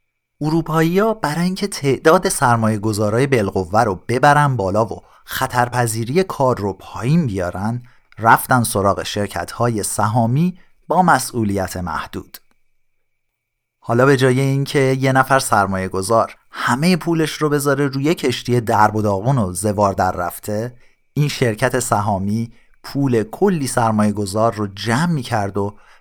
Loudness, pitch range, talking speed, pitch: -18 LUFS, 105-140 Hz, 135 wpm, 120 Hz